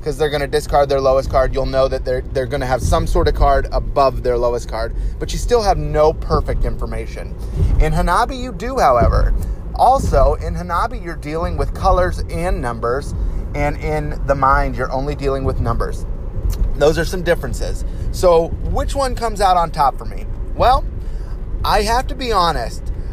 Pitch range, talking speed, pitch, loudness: 115-150 Hz, 180 wpm, 135 Hz, -18 LUFS